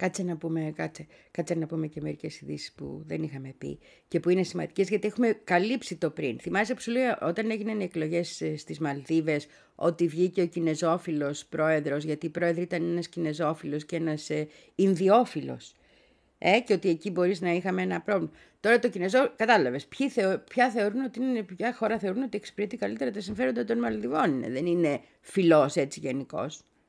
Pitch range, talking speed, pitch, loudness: 155-210 Hz, 175 wpm, 175 Hz, -28 LUFS